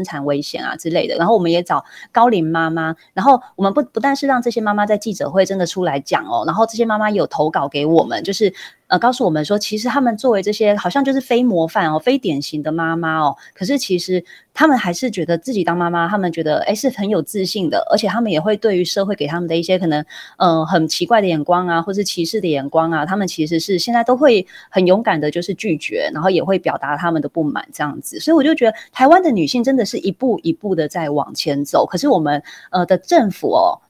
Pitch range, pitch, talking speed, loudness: 165-225 Hz, 185 Hz, 370 characters per minute, -17 LUFS